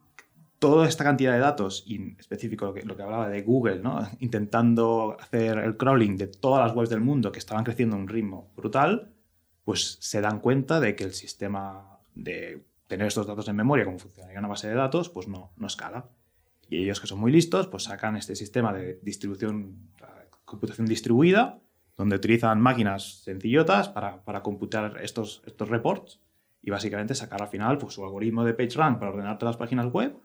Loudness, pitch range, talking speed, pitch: -26 LUFS, 100-120 Hz, 195 wpm, 110 Hz